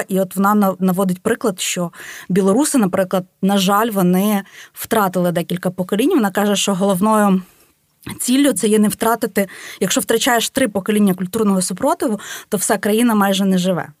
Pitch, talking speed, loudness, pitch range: 200 Hz, 150 wpm, -17 LUFS, 190-225 Hz